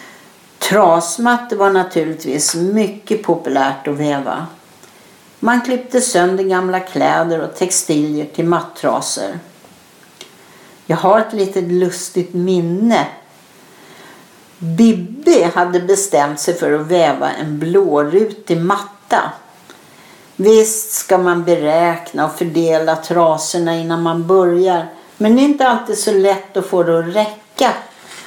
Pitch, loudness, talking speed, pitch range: 180 Hz, -15 LUFS, 115 wpm, 165-205 Hz